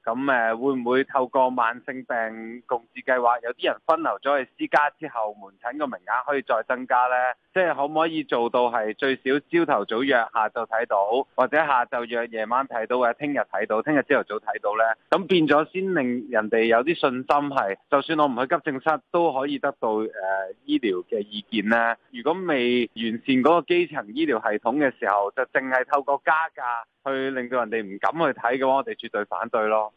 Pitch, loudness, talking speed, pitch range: 130 Hz, -24 LUFS, 305 characters per minute, 115-150 Hz